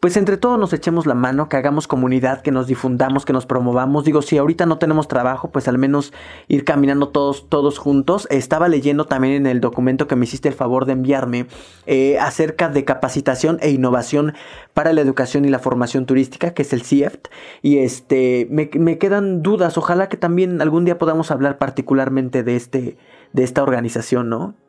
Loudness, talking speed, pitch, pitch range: -17 LUFS, 195 wpm, 140 Hz, 130-155 Hz